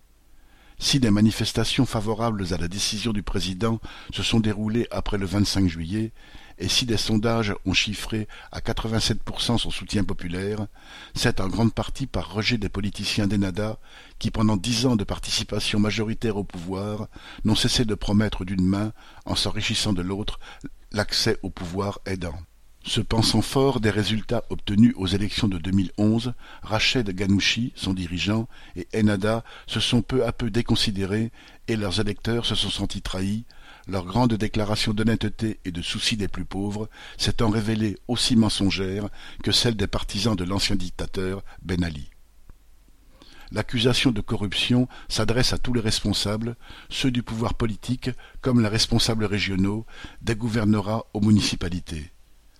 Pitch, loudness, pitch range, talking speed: 105 Hz, -24 LUFS, 95-115 Hz, 150 wpm